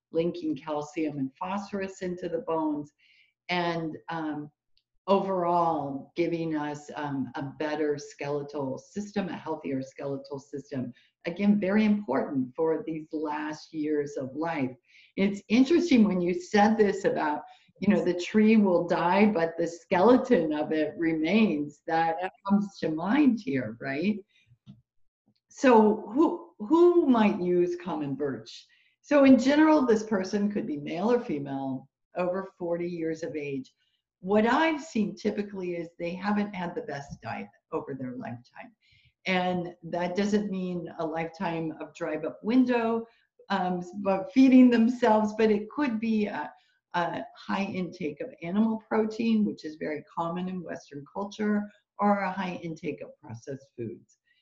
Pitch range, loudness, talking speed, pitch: 155-210 Hz, -27 LUFS, 145 wpm, 175 Hz